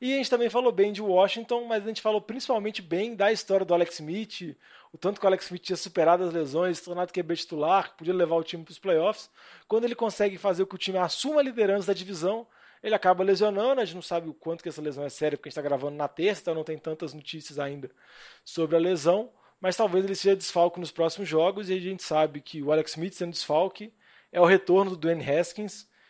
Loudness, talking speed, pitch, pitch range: -27 LUFS, 245 wpm, 185 Hz, 165-205 Hz